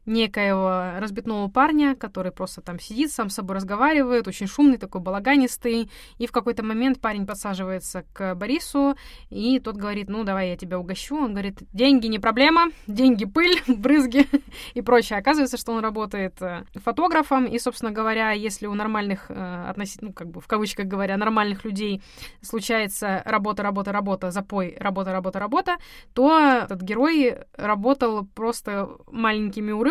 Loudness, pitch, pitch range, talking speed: -23 LUFS, 220 Hz, 200-255 Hz, 150 wpm